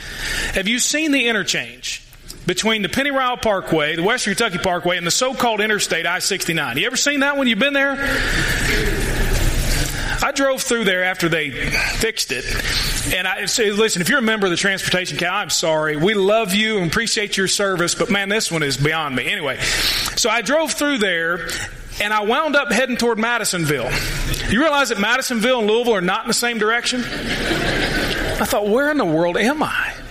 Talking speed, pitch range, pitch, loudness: 195 wpm, 180-245 Hz, 215 Hz, -18 LUFS